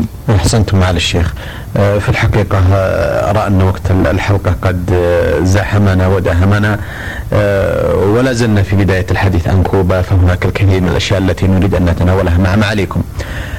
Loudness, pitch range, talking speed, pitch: -12 LUFS, 90-100 Hz, 130 wpm, 95 Hz